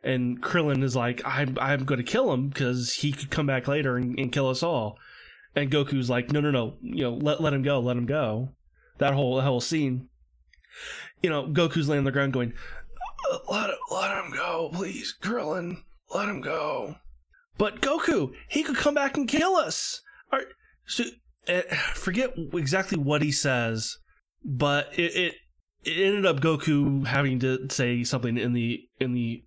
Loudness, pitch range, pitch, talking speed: -27 LUFS, 125-170 Hz, 140 Hz, 185 wpm